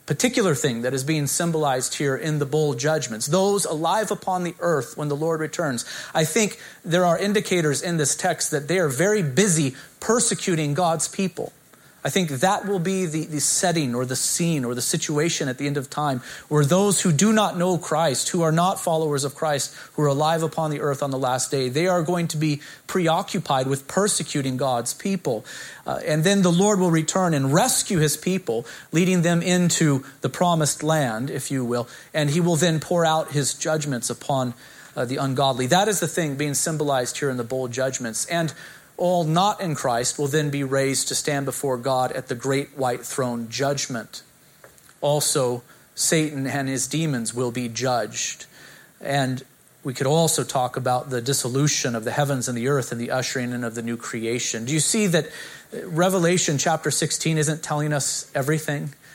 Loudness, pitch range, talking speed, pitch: -22 LUFS, 135-170 Hz, 195 wpm, 150 Hz